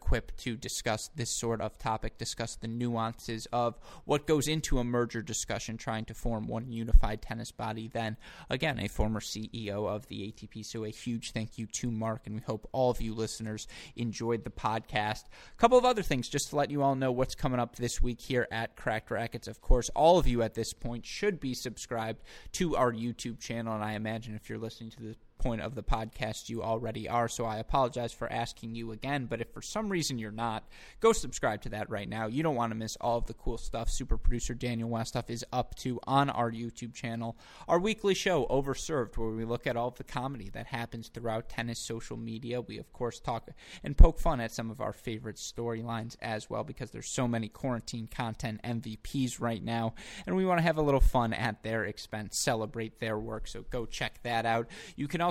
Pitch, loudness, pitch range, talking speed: 115 Hz, -33 LUFS, 110-125 Hz, 220 wpm